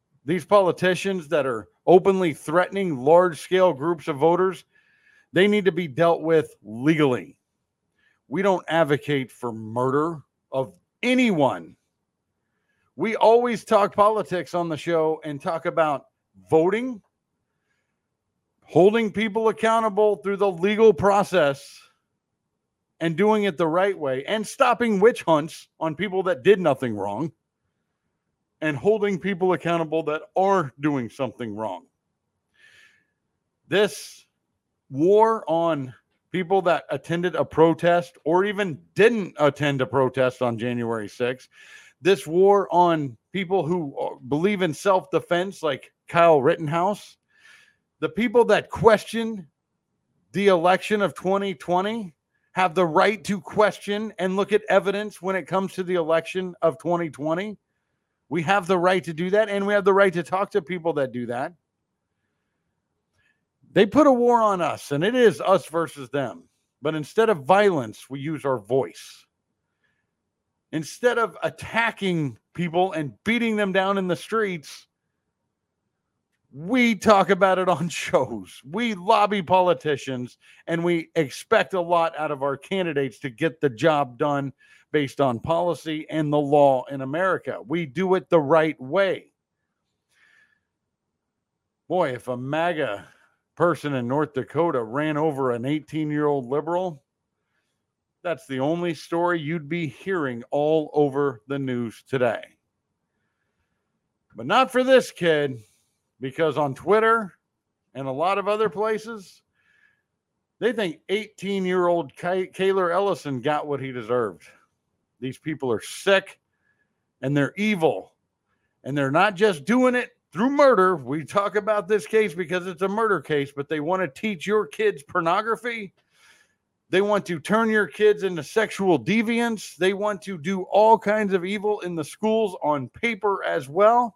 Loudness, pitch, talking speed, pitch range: -23 LUFS, 175 Hz, 140 wpm, 150-200 Hz